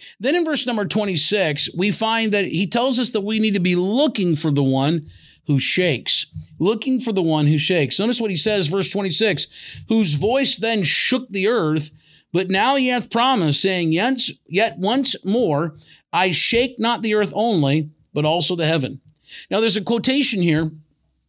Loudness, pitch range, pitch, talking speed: -18 LUFS, 160-225 Hz, 195 Hz, 180 wpm